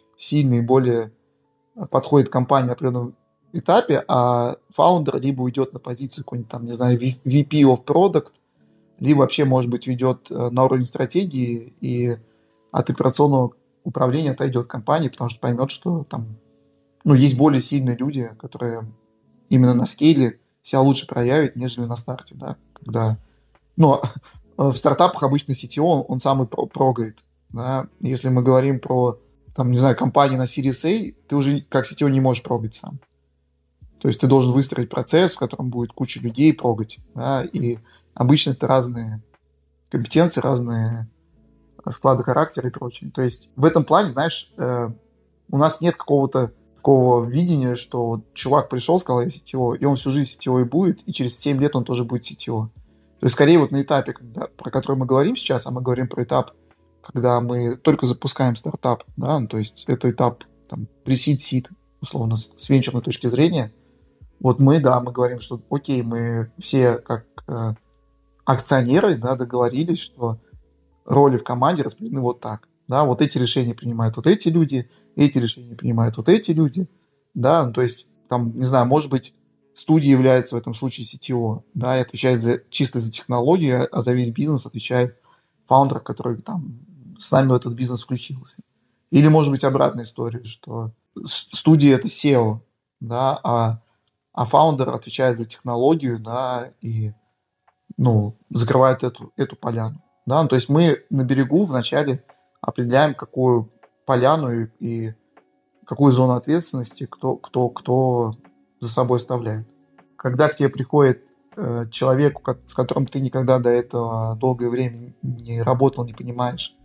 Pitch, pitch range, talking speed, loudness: 125 Hz, 120-140 Hz, 160 wpm, -20 LUFS